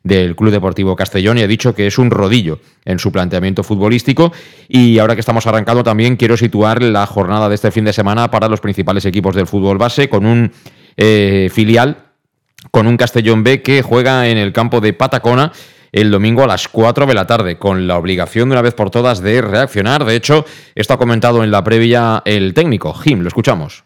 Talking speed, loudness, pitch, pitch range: 210 wpm, -12 LUFS, 110 Hz, 100-120 Hz